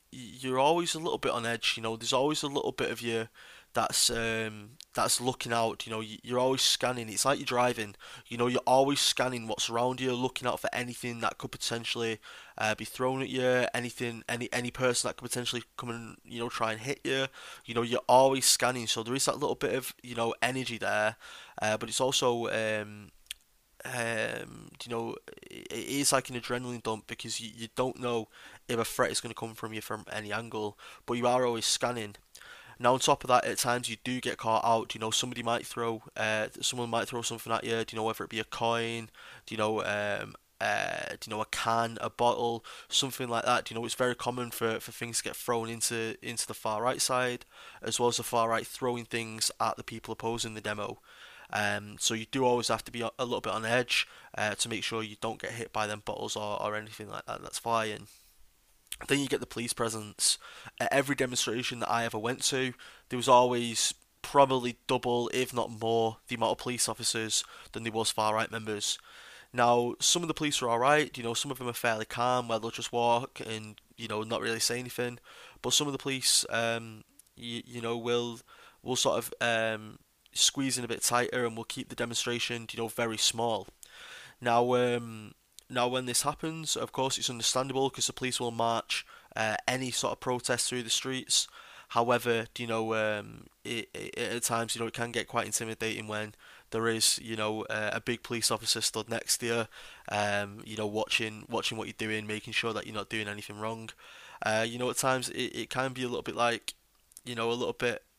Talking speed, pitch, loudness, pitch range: 225 wpm, 115 Hz, -30 LUFS, 110-125 Hz